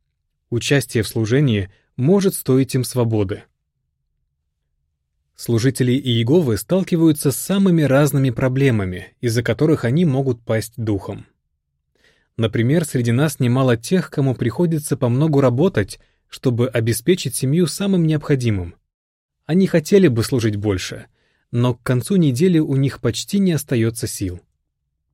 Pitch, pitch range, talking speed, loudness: 125 Hz, 105-150 Hz, 115 wpm, -18 LUFS